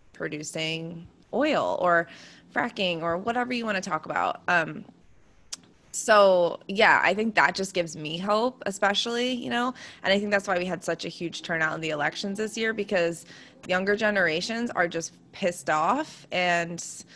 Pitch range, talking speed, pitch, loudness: 170-220 Hz, 170 wpm, 185 Hz, -26 LUFS